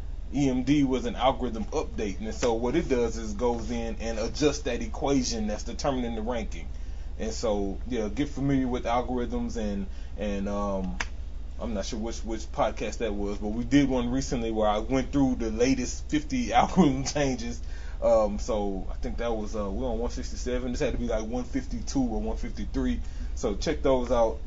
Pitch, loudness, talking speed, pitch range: 120 Hz, -29 LUFS, 185 wpm, 100-135 Hz